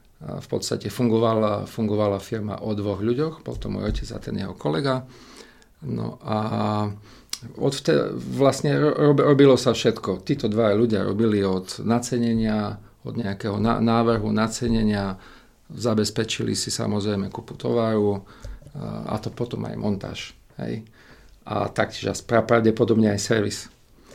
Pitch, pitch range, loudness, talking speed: 115 Hz, 105-120 Hz, -23 LUFS, 135 wpm